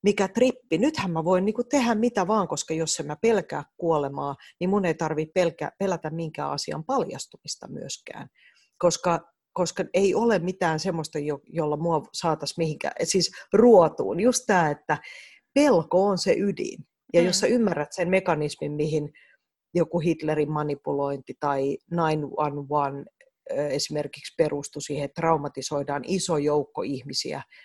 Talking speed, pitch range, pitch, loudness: 140 wpm, 150-190 Hz, 165 Hz, -25 LUFS